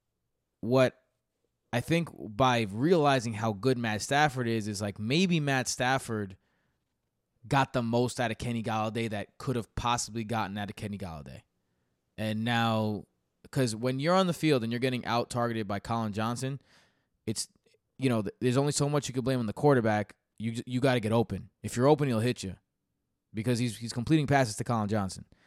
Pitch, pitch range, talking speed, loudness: 120 Hz, 110-130 Hz, 190 wpm, -29 LUFS